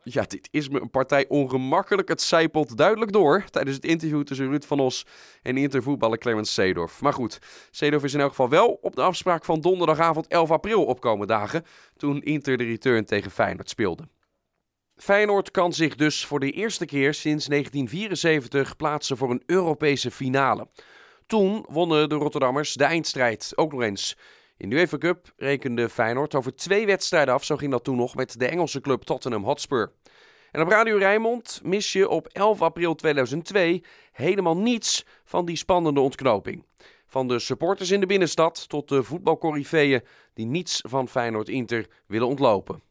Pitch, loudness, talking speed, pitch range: 150 Hz, -24 LUFS, 170 wpm, 135-170 Hz